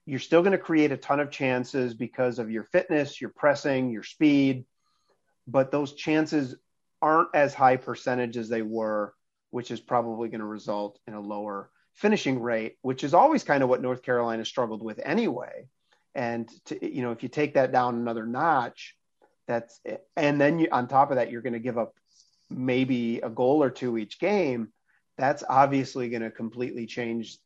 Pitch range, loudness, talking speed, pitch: 115-140 Hz, -26 LUFS, 190 wpm, 125 Hz